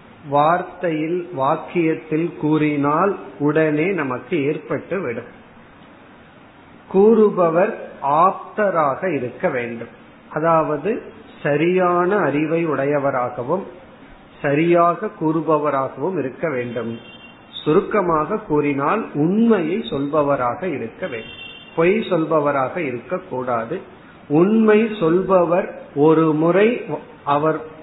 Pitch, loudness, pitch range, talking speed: 160 Hz, -19 LUFS, 145-180 Hz, 65 wpm